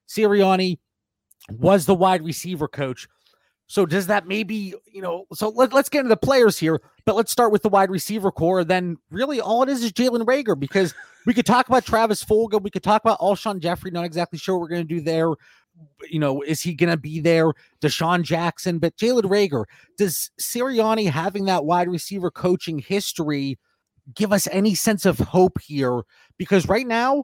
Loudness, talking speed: -21 LUFS, 195 wpm